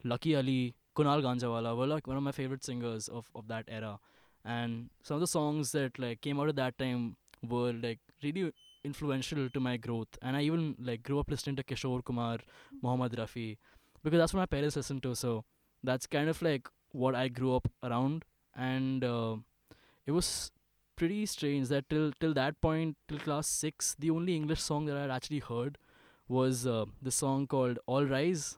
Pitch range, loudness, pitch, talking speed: 120-150 Hz, -34 LUFS, 130 Hz, 195 wpm